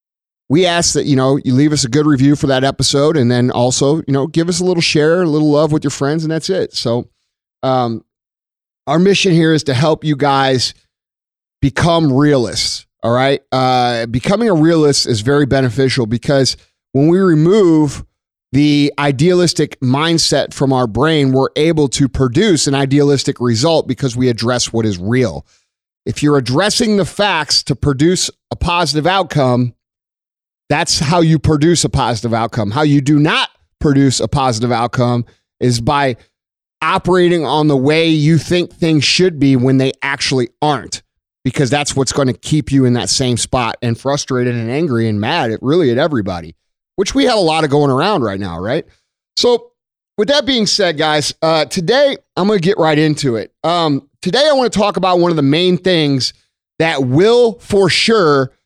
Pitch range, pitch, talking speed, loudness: 130-160 Hz, 145 Hz, 185 wpm, -13 LUFS